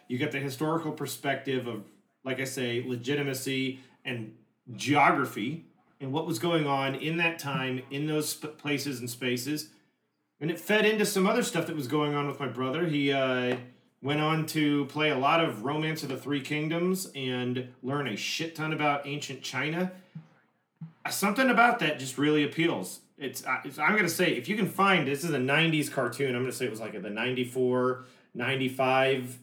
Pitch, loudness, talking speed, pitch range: 145 Hz, -29 LUFS, 190 wpm, 130-160 Hz